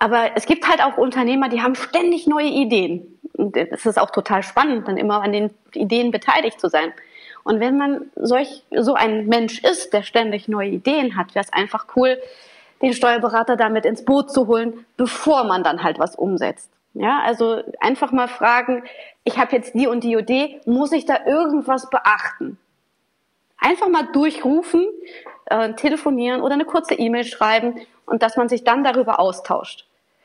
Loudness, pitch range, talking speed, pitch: -19 LUFS, 225-280 Hz, 175 wpm, 245 Hz